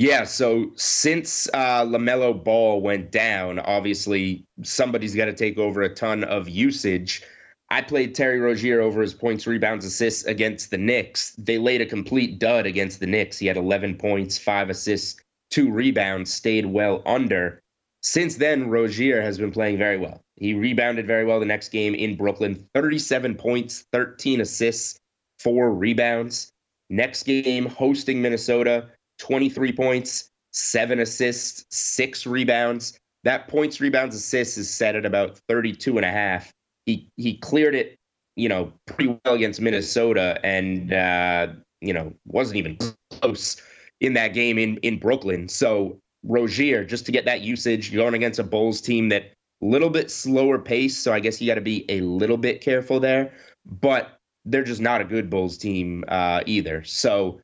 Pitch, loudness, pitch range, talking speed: 115 Hz, -22 LUFS, 100-120 Hz, 165 wpm